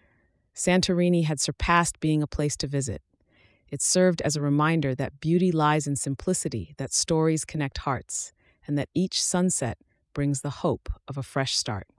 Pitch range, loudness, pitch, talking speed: 135-165 Hz, -25 LUFS, 150 Hz, 165 wpm